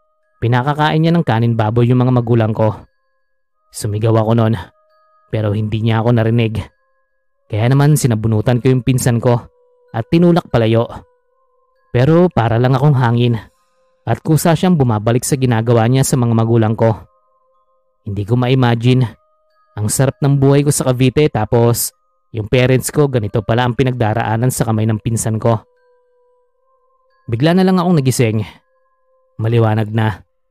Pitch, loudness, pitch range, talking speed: 125 Hz, -14 LUFS, 115-175 Hz, 145 wpm